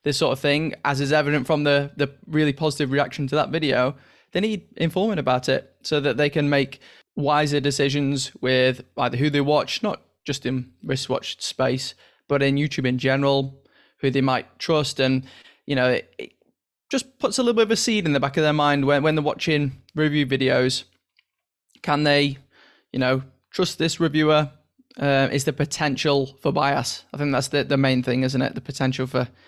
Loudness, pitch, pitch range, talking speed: -22 LUFS, 140 Hz, 135-150 Hz, 195 wpm